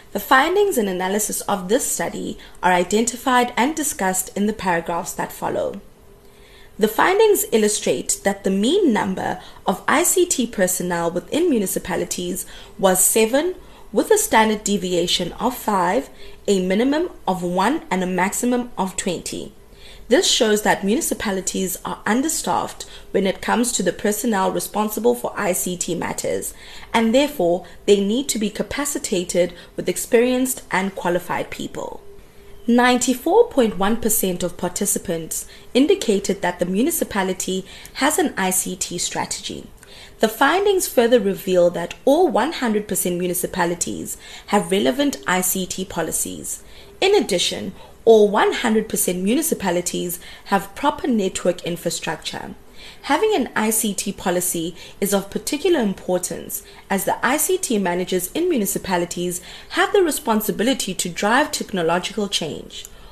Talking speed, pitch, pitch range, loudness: 120 wpm, 205 Hz, 185-250 Hz, -20 LUFS